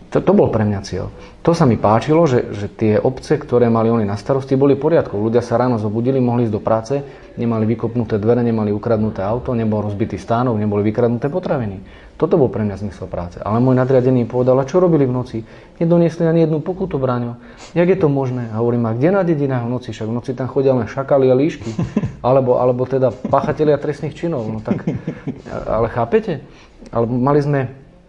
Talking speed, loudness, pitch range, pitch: 205 wpm, -17 LUFS, 110-140 Hz, 125 Hz